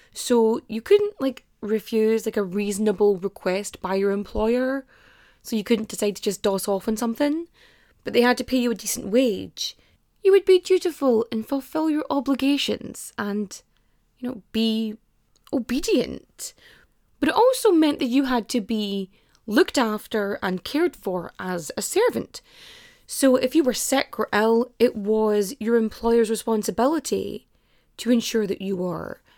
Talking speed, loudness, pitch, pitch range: 160 wpm, -23 LUFS, 230 Hz, 210-275 Hz